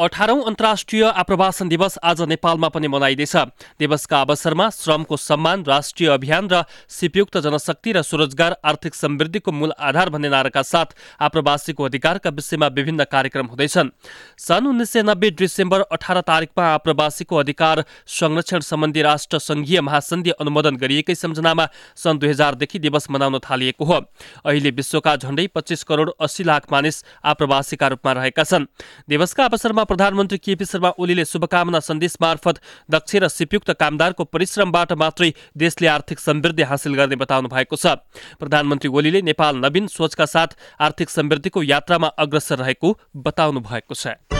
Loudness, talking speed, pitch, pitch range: -18 LUFS, 145 wpm, 160 Hz, 150-175 Hz